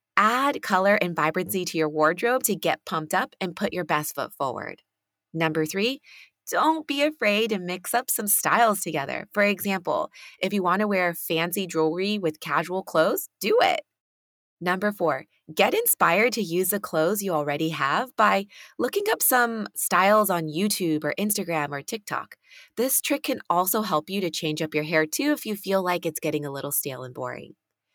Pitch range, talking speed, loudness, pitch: 160-215 Hz, 185 wpm, -24 LUFS, 185 Hz